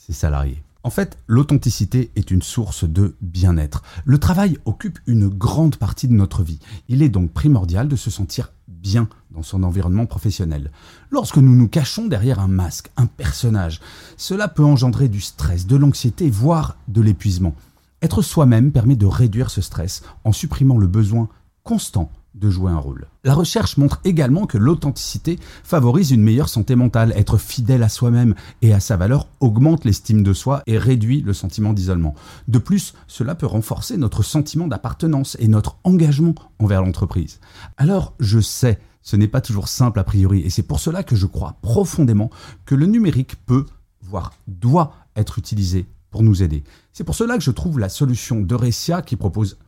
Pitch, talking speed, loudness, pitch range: 110 Hz, 175 wpm, -18 LUFS, 95-135 Hz